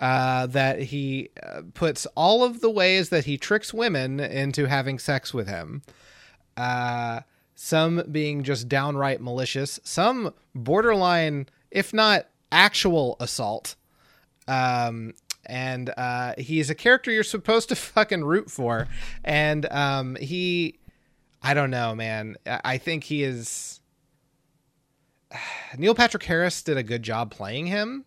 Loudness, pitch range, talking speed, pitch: -24 LUFS, 130-175 Hz, 135 wpm, 140 Hz